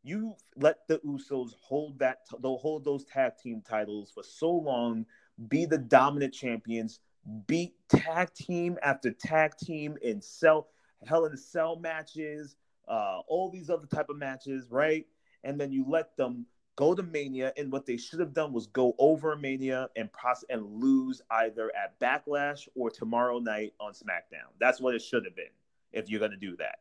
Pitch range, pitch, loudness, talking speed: 120-160 Hz, 140 Hz, -31 LUFS, 185 wpm